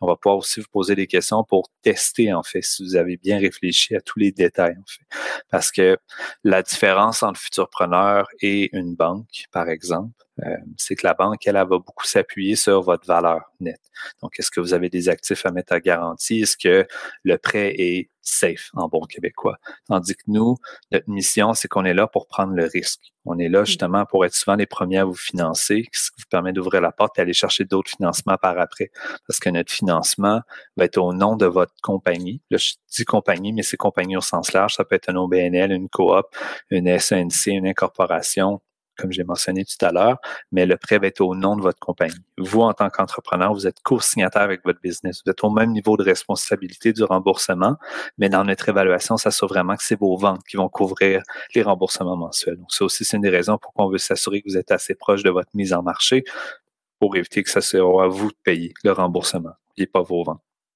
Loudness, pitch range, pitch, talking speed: -20 LUFS, 90-100 Hz, 95 Hz, 225 wpm